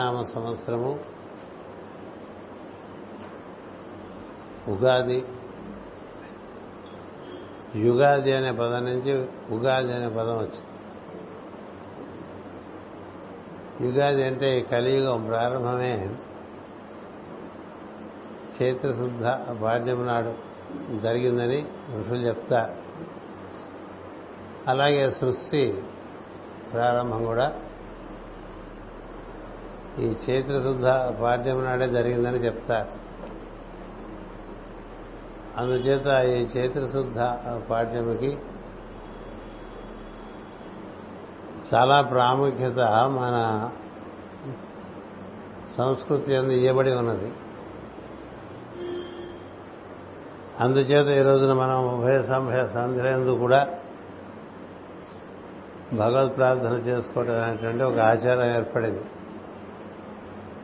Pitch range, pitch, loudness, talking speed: 115-130 Hz, 125 Hz, -24 LUFS, 55 wpm